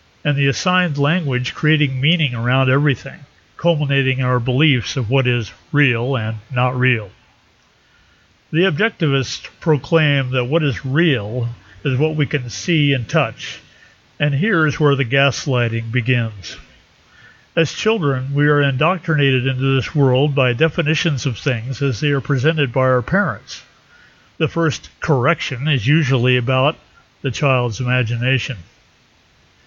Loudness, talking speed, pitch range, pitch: -17 LUFS, 140 wpm, 125-150 Hz, 135 Hz